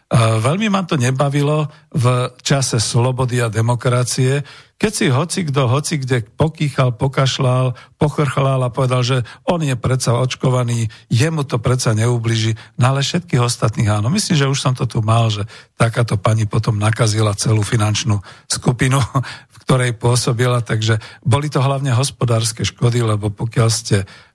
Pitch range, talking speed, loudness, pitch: 115-140 Hz, 155 wpm, -17 LUFS, 125 Hz